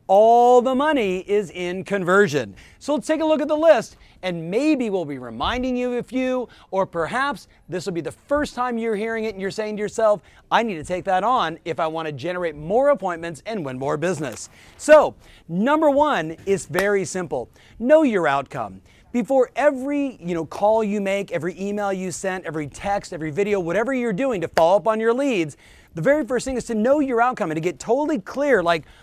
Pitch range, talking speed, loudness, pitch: 175-250 Hz, 215 wpm, -21 LUFS, 205 Hz